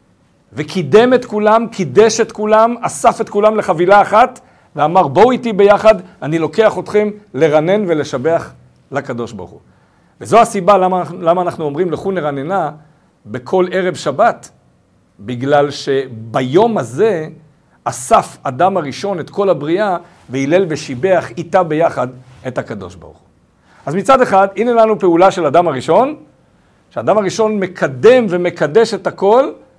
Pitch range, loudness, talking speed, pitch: 150-210 Hz, -13 LUFS, 135 wpm, 185 Hz